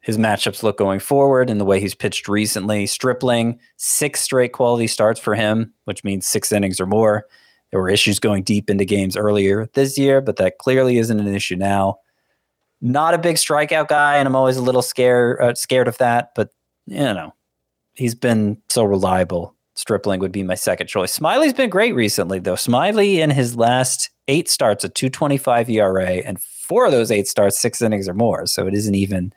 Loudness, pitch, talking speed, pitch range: -18 LUFS, 110 Hz, 200 wpm, 100-130 Hz